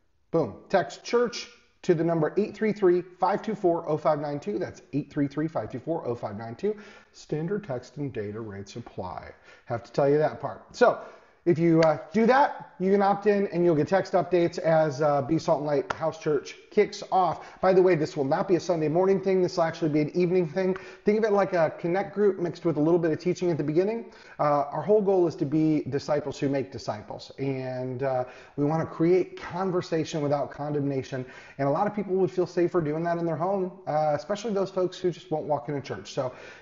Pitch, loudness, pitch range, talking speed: 165 Hz, -26 LUFS, 145-185 Hz, 205 wpm